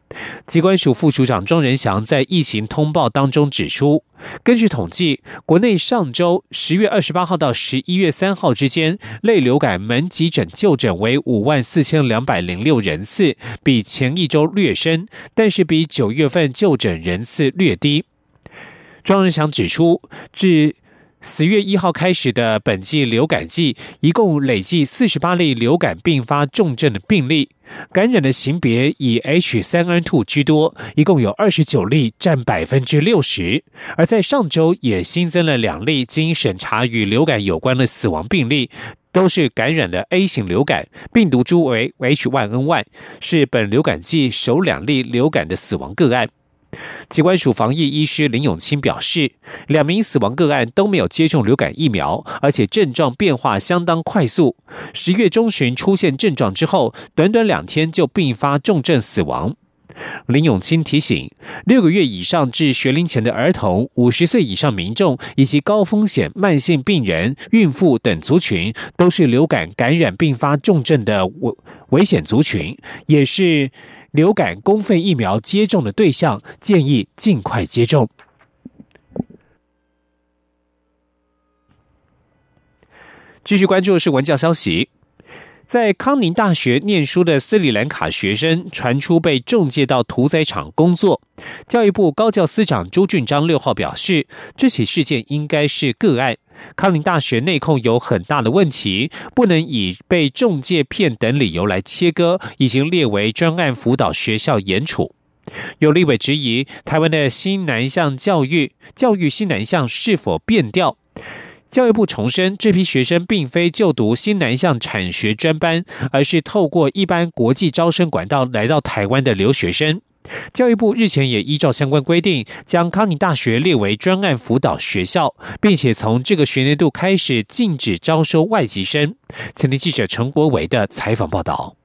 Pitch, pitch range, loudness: 150 Hz, 130-175 Hz, -16 LUFS